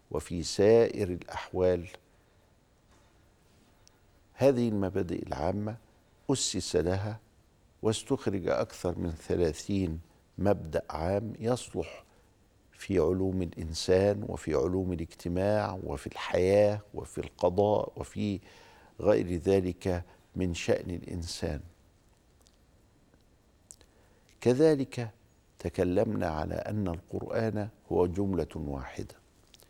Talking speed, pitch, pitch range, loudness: 80 wpm, 95 Hz, 90-105 Hz, -30 LUFS